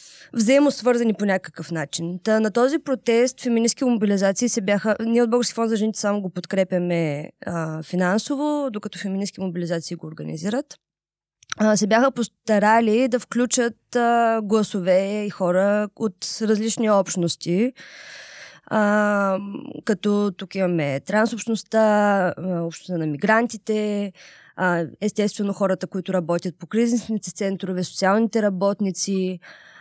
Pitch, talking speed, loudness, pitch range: 205 Hz, 120 wpm, -22 LUFS, 185-225 Hz